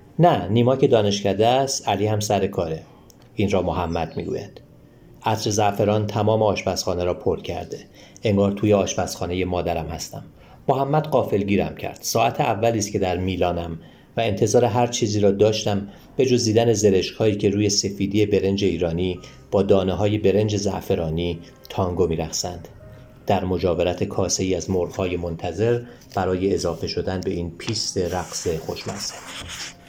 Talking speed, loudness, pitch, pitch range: 145 wpm, -22 LUFS, 100 Hz, 95-110 Hz